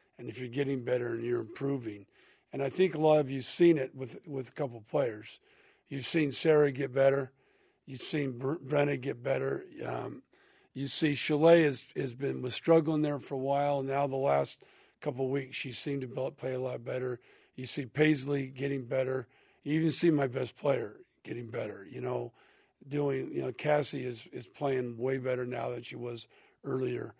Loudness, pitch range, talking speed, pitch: -32 LUFS, 130-145 Hz, 195 wpm, 135 Hz